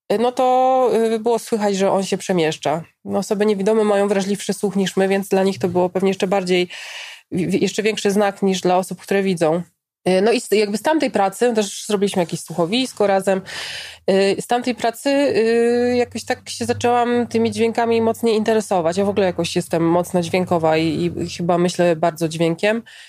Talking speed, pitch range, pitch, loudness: 170 wpm, 180-230 Hz, 200 Hz, -19 LUFS